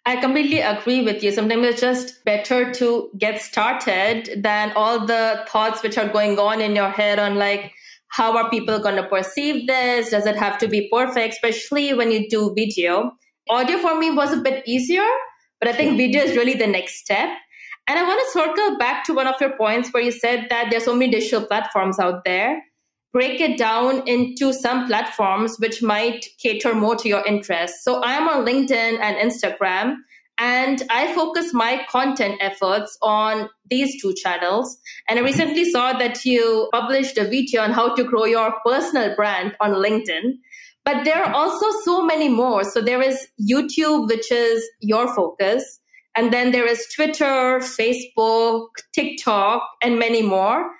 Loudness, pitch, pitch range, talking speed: -20 LUFS, 235 Hz, 215-260 Hz, 180 wpm